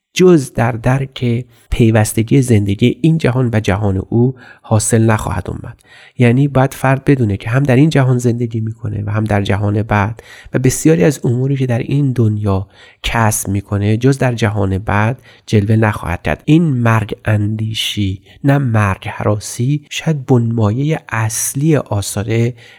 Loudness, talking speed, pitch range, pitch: -15 LUFS, 145 wpm, 105-130 Hz, 115 Hz